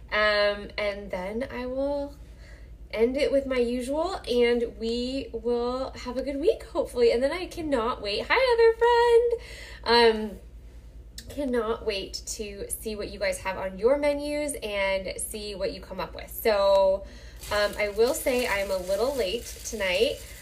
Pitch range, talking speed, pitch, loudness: 205-290 Hz, 160 wpm, 240 Hz, -26 LUFS